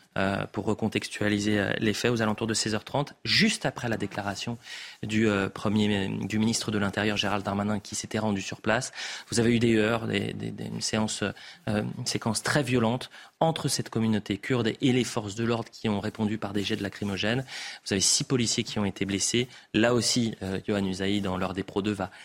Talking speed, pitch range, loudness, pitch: 200 wpm, 100-115 Hz, -27 LUFS, 110 Hz